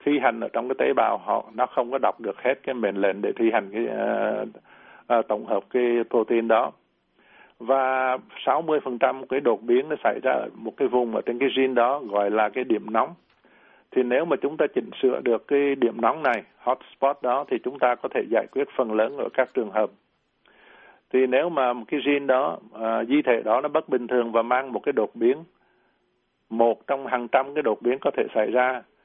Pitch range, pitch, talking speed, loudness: 120-145 Hz, 130 Hz, 230 wpm, -24 LUFS